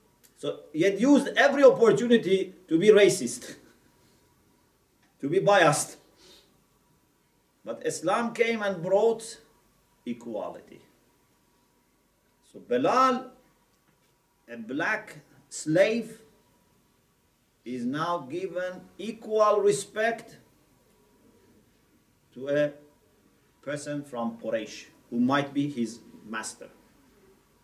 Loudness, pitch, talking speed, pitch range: -26 LUFS, 200 Hz, 85 wpm, 145-235 Hz